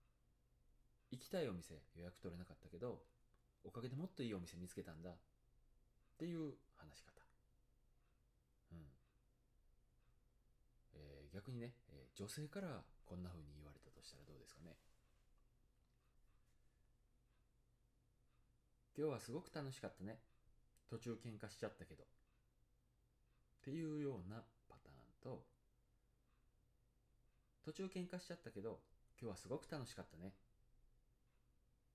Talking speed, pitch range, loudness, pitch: 240 characters per minute, 85-125 Hz, -53 LUFS, 115 Hz